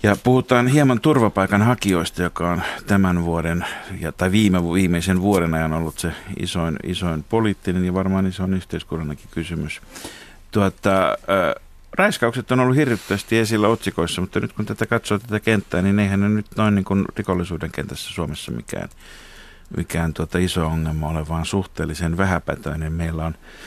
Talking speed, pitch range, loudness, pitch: 155 wpm, 85-105 Hz, -21 LUFS, 95 Hz